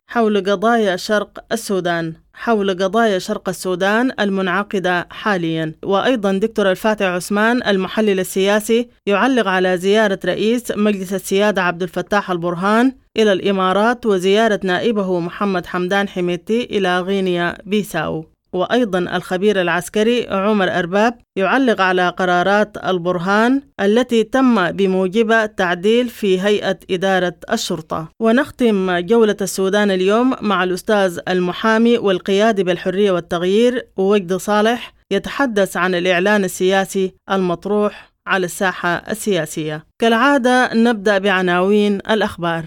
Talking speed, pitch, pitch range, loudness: 105 wpm, 195 Hz, 185-220 Hz, -17 LUFS